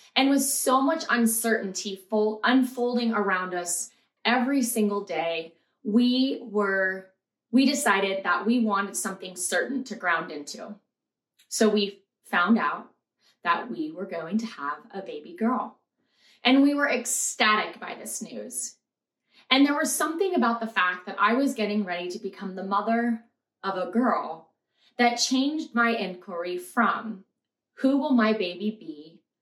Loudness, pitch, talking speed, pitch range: -25 LUFS, 220 Hz, 150 wpm, 190-245 Hz